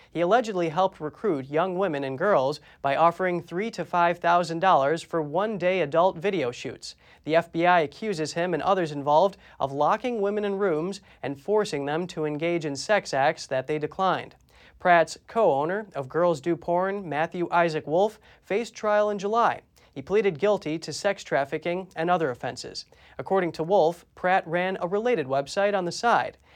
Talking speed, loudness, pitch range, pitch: 170 wpm, -25 LUFS, 155-200 Hz, 175 Hz